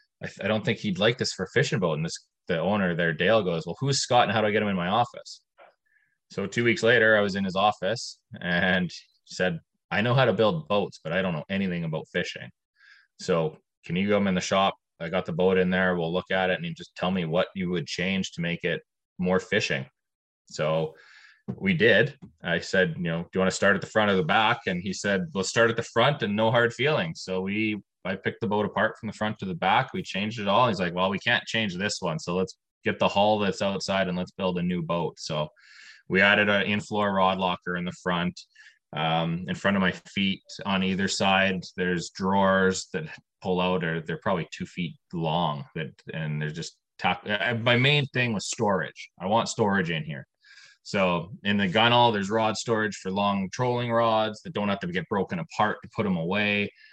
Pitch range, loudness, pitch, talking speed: 90-115 Hz, -26 LUFS, 100 Hz, 230 wpm